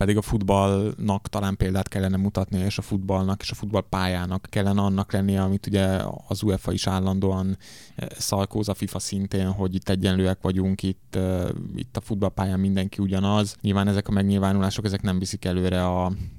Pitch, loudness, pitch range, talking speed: 95 Hz, -25 LUFS, 95-100 Hz, 165 wpm